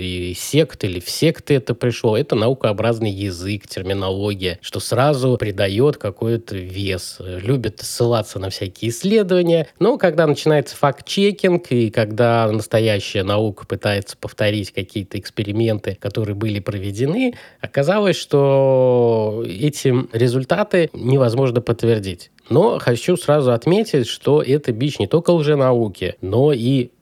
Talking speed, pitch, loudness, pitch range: 120 wpm, 120 Hz, -18 LUFS, 105-140 Hz